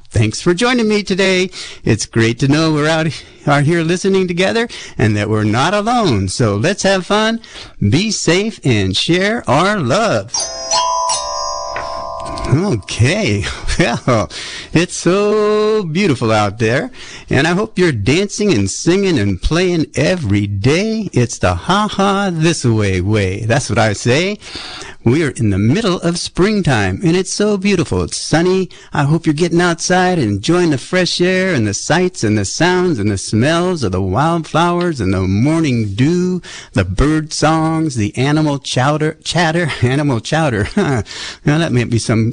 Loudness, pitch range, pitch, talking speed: -15 LUFS, 110-180 Hz, 155 Hz, 160 wpm